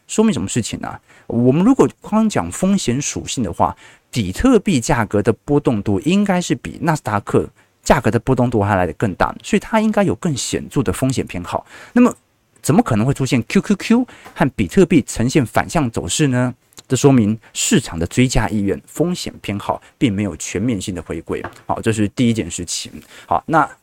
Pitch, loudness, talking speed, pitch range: 125 Hz, -18 LUFS, 295 characters per minute, 105-170 Hz